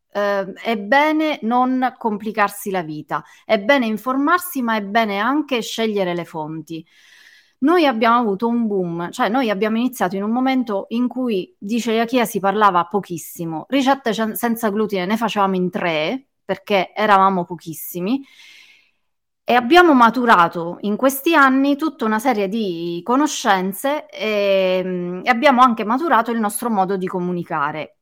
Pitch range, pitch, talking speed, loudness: 190-255 Hz, 220 Hz, 145 wpm, -18 LUFS